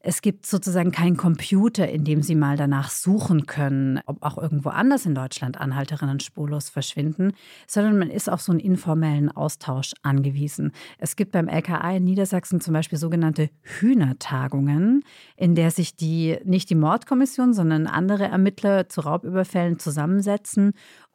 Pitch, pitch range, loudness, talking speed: 170 Hz, 150-190 Hz, -22 LUFS, 150 wpm